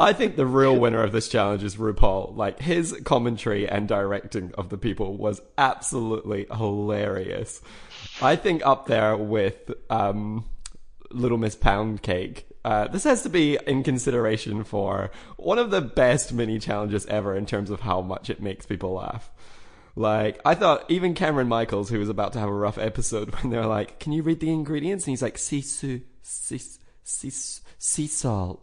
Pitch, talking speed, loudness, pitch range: 110 Hz, 180 wpm, -25 LUFS, 105-130 Hz